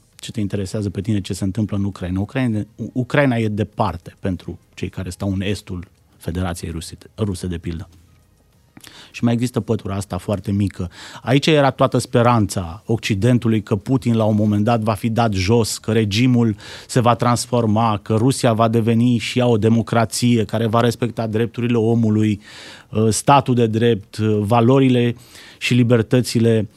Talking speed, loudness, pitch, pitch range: 155 wpm, -18 LUFS, 110 Hz, 100-120 Hz